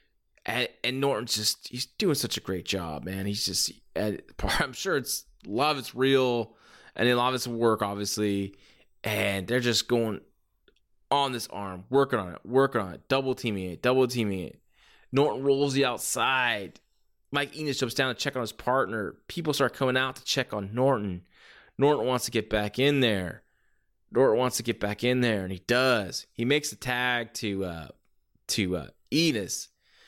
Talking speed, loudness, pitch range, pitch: 180 wpm, -27 LUFS, 100-130 Hz, 120 Hz